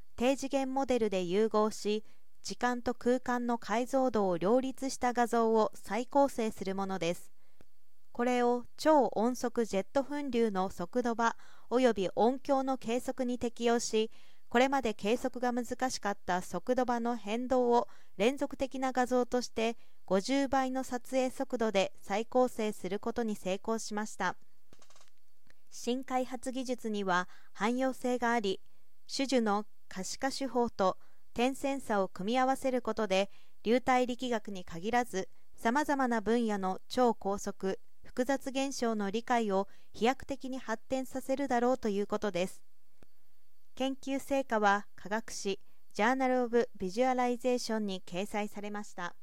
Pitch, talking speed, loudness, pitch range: 240 Hz, 280 characters per minute, -33 LUFS, 210-255 Hz